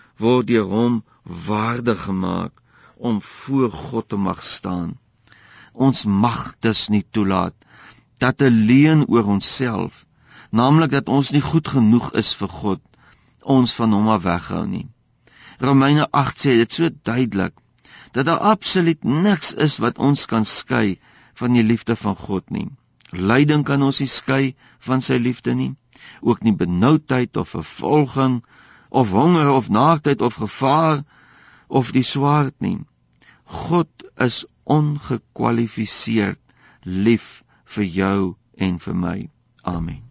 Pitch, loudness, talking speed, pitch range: 120 Hz, -19 LUFS, 135 wpm, 105-140 Hz